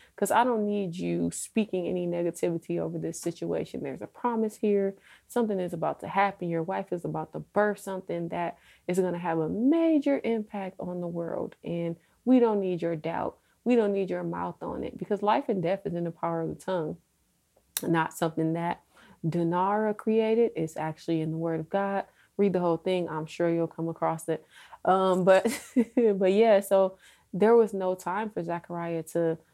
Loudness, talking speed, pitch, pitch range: -28 LUFS, 195 wpm, 180 Hz, 165-205 Hz